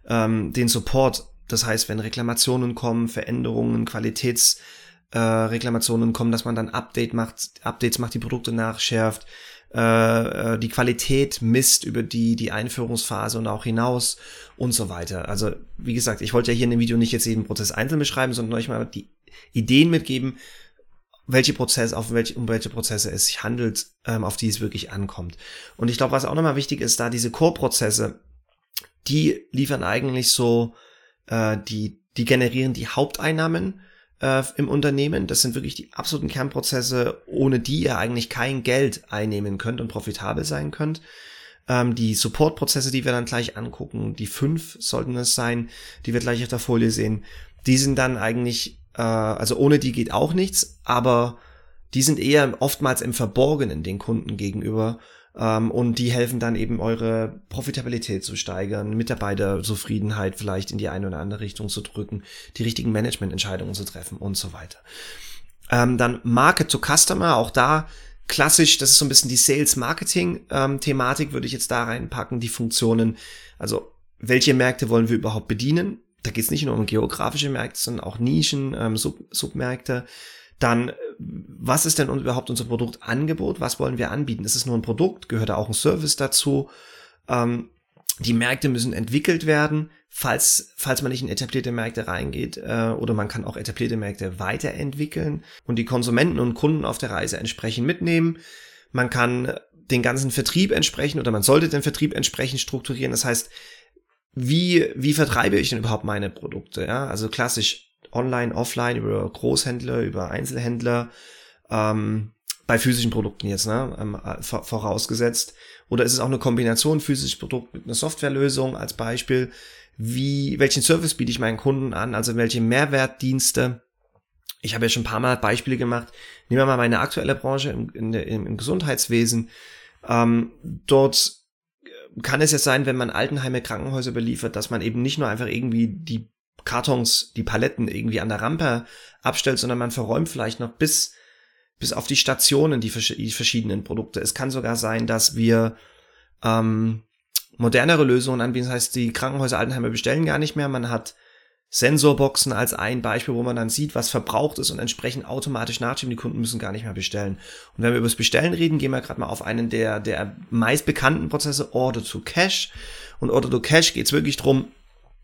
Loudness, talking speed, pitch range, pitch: -22 LUFS, 170 wpm, 110-135 Hz, 120 Hz